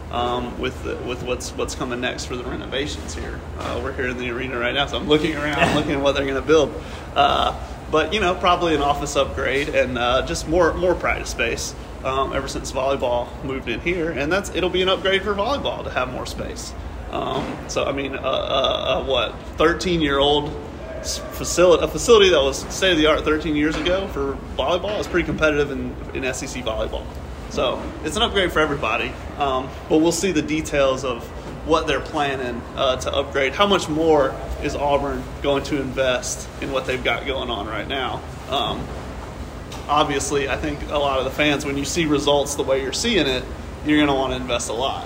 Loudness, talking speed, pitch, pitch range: -21 LUFS, 205 wpm, 145 Hz, 130-155 Hz